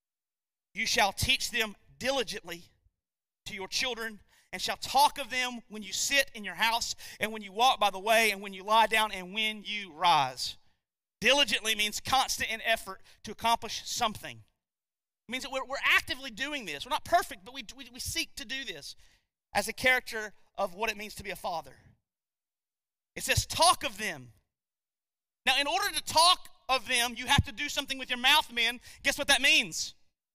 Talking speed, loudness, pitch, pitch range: 190 wpm, -28 LUFS, 230 Hz, 210-275 Hz